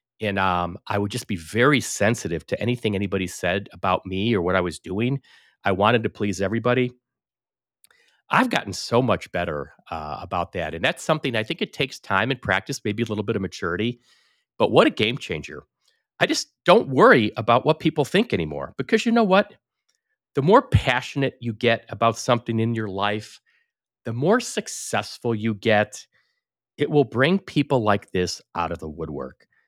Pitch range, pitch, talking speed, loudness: 100-130 Hz, 115 Hz, 185 wpm, -22 LUFS